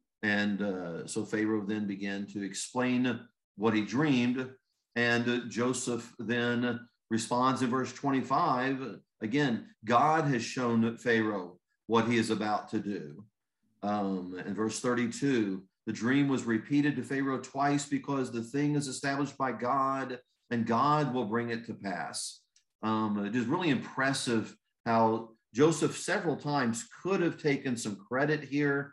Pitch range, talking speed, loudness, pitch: 110-135 Hz, 145 wpm, -31 LUFS, 120 Hz